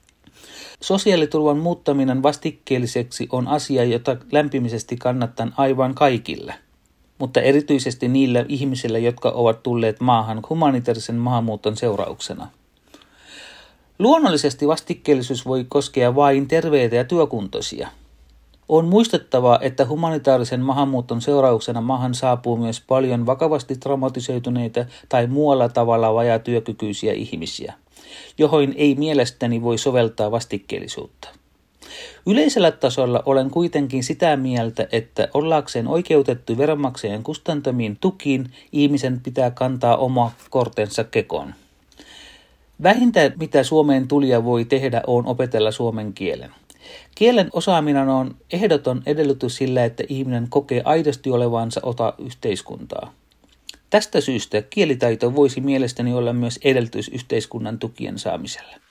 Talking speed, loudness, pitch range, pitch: 105 wpm, -20 LUFS, 120-145 Hz, 130 Hz